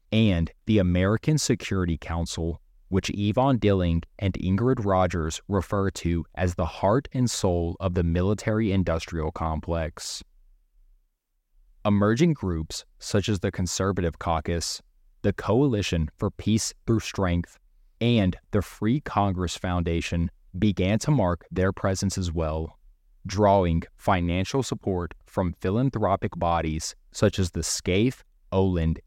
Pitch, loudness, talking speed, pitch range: 95 Hz, -26 LUFS, 120 wpm, 85-105 Hz